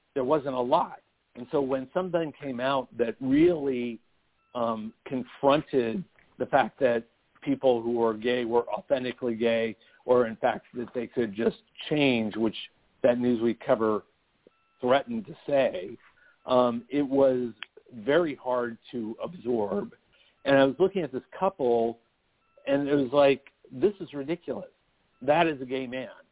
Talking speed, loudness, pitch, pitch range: 150 wpm, -27 LUFS, 130 Hz, 120-140 Hz